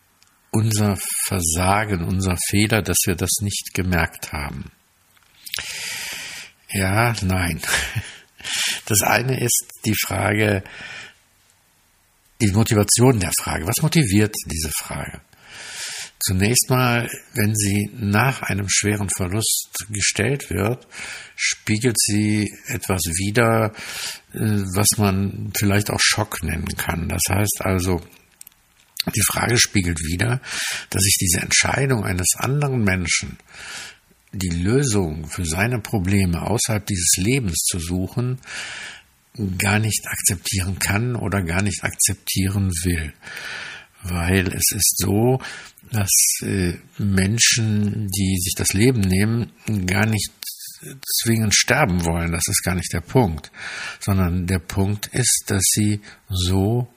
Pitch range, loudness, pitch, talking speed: 95-110 Hz, -20 LUFS, 100 Hz, 115 wpm